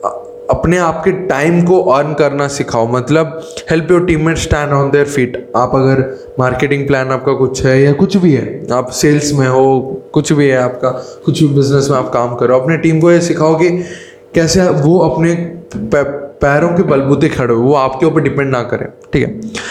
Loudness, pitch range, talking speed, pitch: -12 LUFS, 130-165 Hz, 190 wpm, 145 Hz